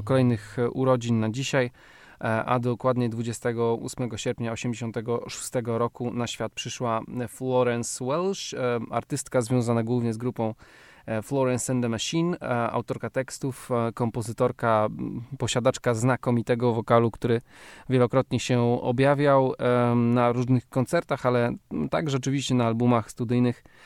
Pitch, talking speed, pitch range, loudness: 120 Hz, 110 wpm, 115-130 Hz, -26 LUFS